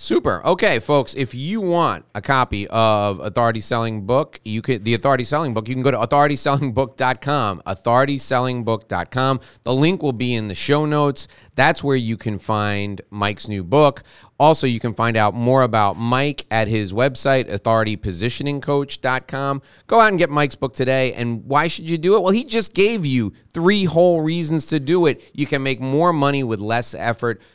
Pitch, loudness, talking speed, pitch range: 130 Hz, -19 LUFS, 185 wpm, 115-145 Hz